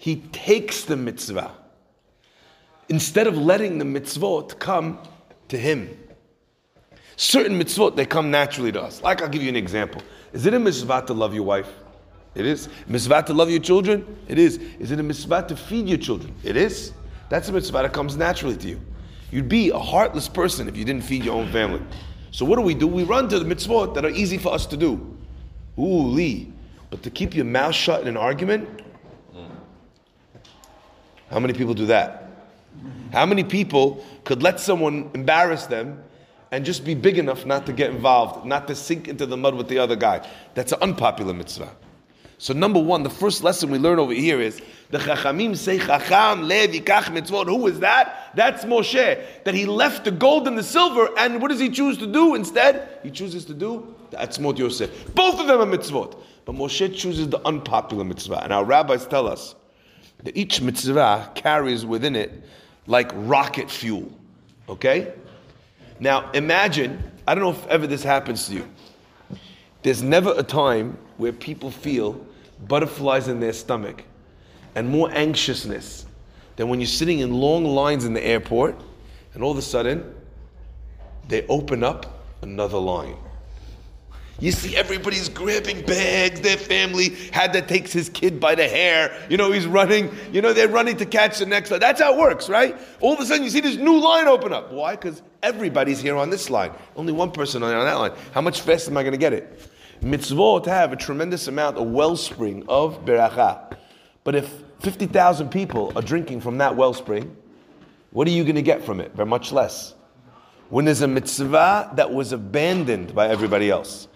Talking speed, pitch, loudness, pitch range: 190 wpm, 155 Hz, -21 LUFS, 125-190 Hz